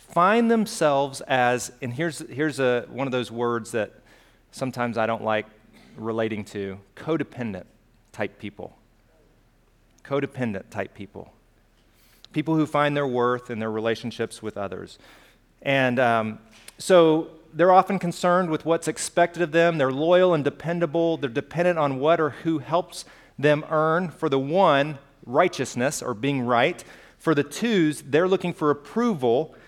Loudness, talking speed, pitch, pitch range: -24 LUFS, 145 wpm, 140 Hz, 120-165 Hz